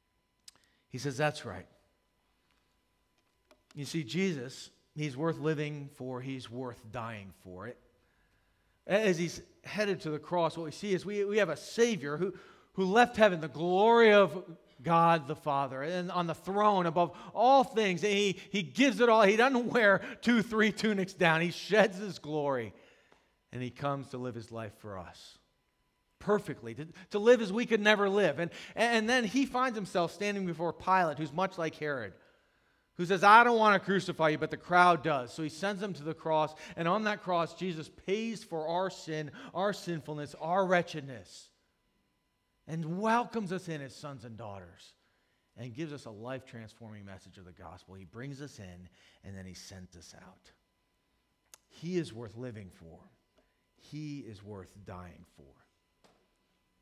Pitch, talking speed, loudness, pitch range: 165 Hz, 175 wpm, -30 LUFS, 125-195 Hz